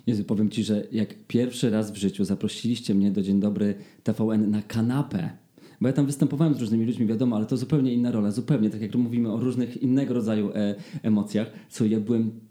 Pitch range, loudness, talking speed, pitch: 105-125 Hz, -25 LUFS, 205 wpm, 110 Hz